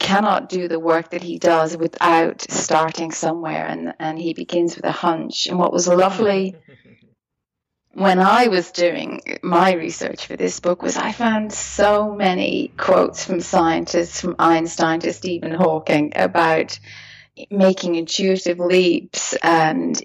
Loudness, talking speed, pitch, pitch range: -19 LUFS, 145 wpm, 175 Hz, 165-190 Hz